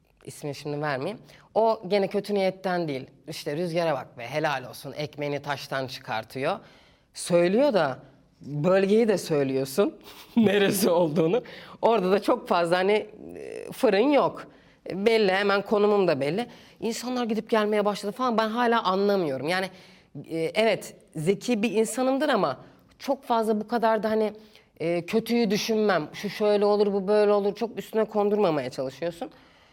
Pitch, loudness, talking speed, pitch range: 200 Hz, -25 LUFS, 135 wpm, 160-220 Hz